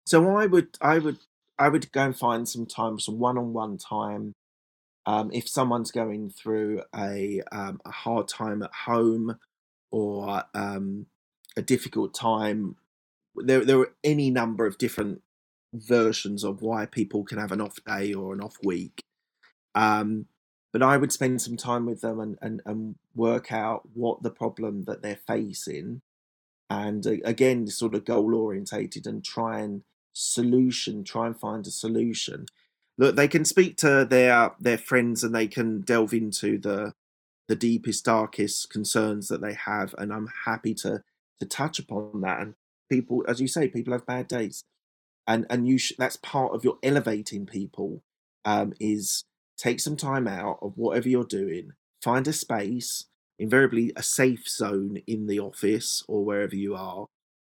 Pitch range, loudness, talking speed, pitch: 105-125 Hz, -26 LUFS, 165 wpm, 115 Hz